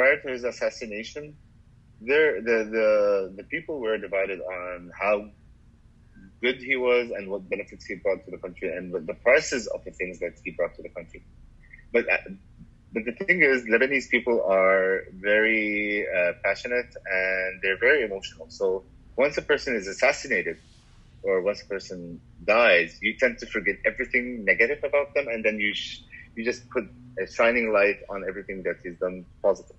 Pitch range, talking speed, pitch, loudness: 95-135 Hz, 170 wpm, 115 Hz, -25 LUFS